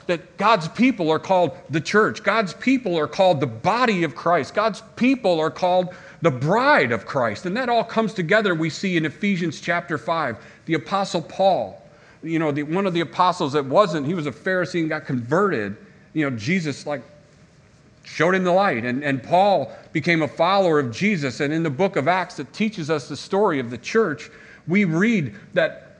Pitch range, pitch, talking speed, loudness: 150-195 Hz, 170 Hz, 195 wpm, -21 LUFS